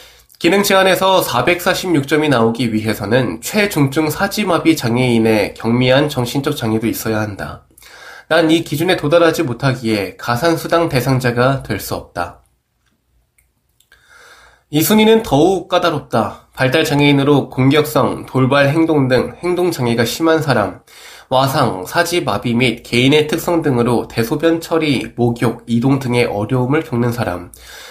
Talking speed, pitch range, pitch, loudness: 285 characters per minute, 120-165 Hz, 135 Hz, -15 LUFS